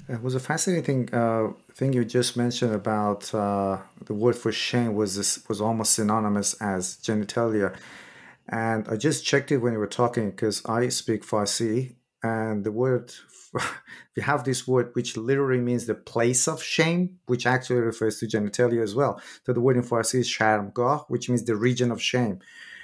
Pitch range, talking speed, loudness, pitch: 110-125 Hz, 185 wpm, -25 LUFS, 120 Hz